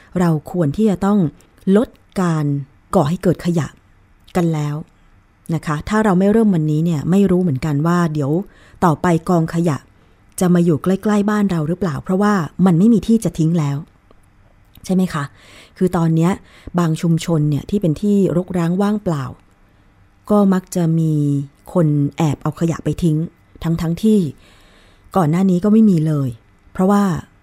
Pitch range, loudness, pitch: 145-185 Hz, -17 LUFS, 165 Hz